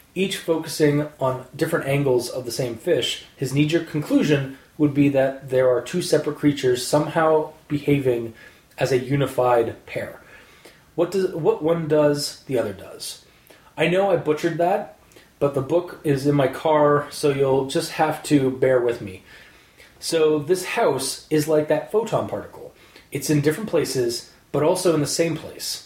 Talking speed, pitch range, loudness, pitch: 170 wpm, 135-160 Hz, -22 LUFS, 150 Hz